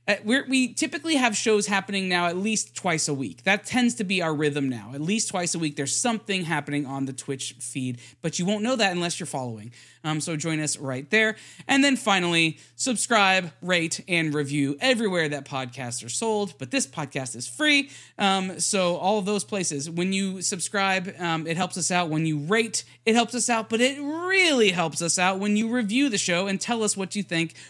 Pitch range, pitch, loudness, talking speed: 155-215 Hz, 185 Hz, -24 LUFS, 220 wpm